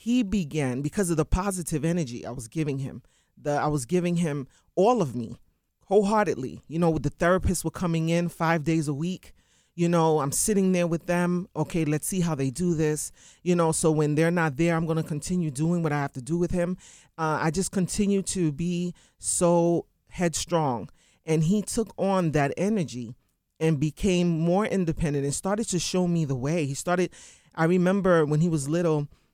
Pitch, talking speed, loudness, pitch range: 165 Hz, 200 wpm, -26 LUFS, 150-180 Hz